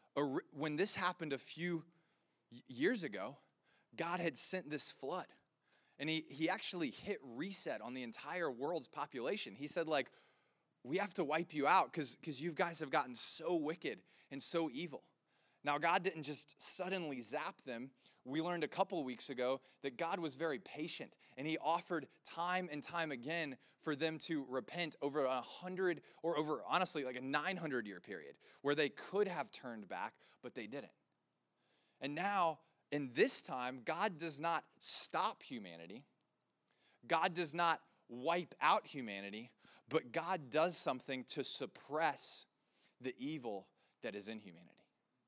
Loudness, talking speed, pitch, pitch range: -40 LUFS, 160 wpm, 155 Hz, 135-170 Hz